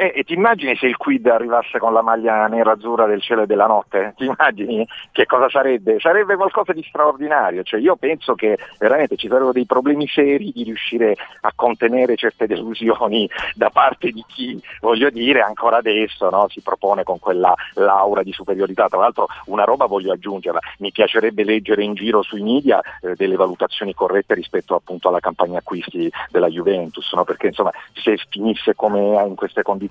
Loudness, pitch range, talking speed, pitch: -18 LUFS, 110-155 Hz, 185 wpm, 120 Hz